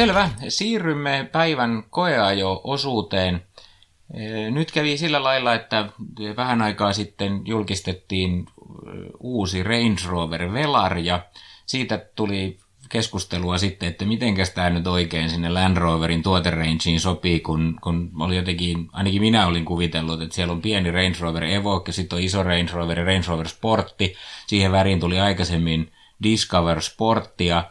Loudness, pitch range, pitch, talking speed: -22 LUFS, 85-110 Hz, 95 Hz, 135 wpm